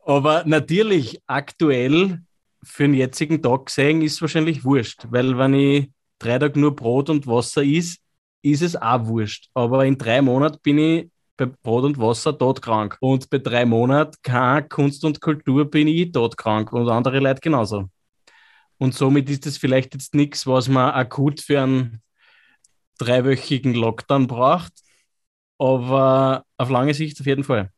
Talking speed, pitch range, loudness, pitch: 160 wpm, 125-150 Hz, -19 LUFS, 135 Hz